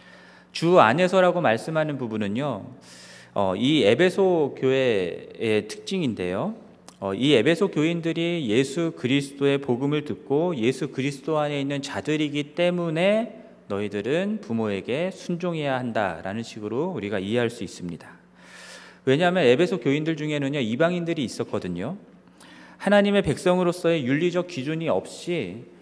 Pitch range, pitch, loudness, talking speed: 115-175 Hz, 145 Hz, -24 LUFS, 320 characters per minute